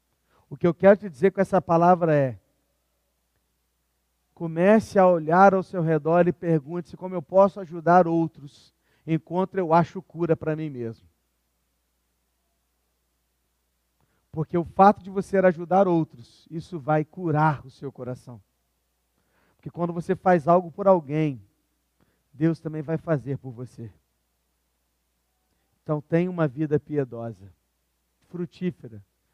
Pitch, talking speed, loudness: 150 Hz, 125 wpm, -23 LUFS